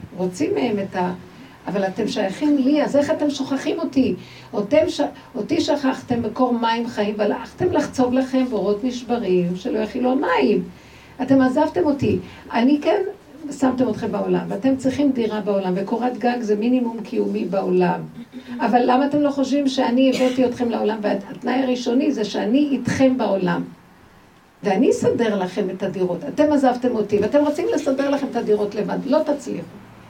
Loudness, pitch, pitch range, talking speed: -20 LUFS, 250 Hz, 210-275 Hz, 155 wpm